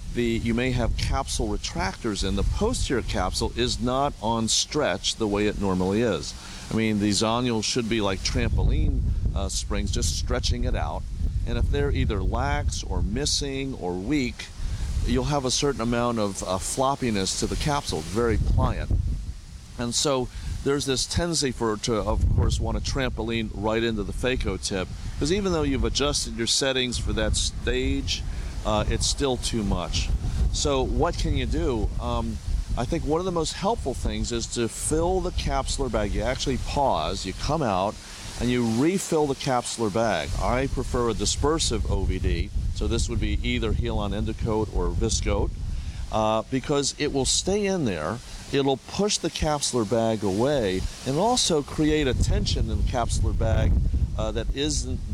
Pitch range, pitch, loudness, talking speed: 95-125 Hz, 110 Hz, -26 LUFS, 175 wpm